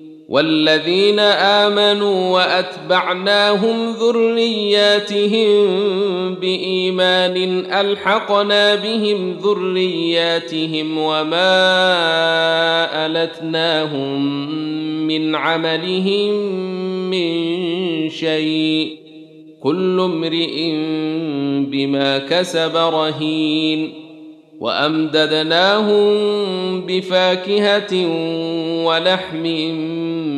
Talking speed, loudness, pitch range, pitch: 45 wpm, -16 LUFS, 155-195 Hz, 170 Hz